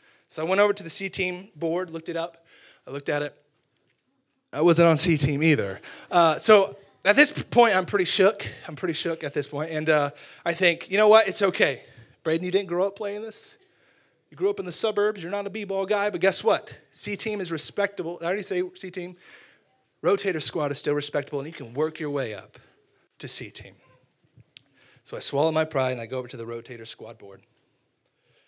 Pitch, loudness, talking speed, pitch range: 170 Hz, -24 LUFS, 220 wpm, 145-195 Hz